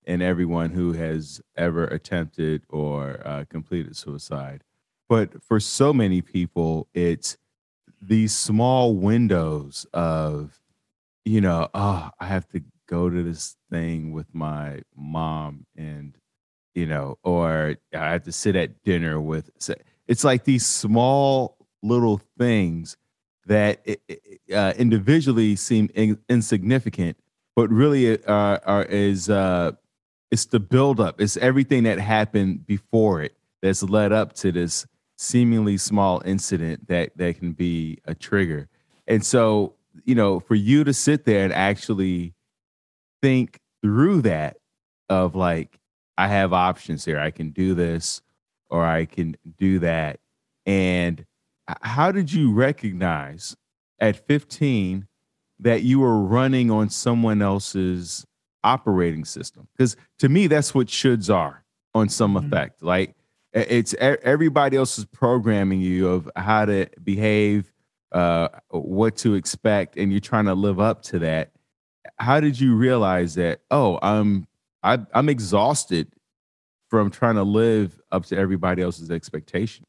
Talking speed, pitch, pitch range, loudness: 135 wpm, 100 Hz, 85-115 Hz, -22 LUFS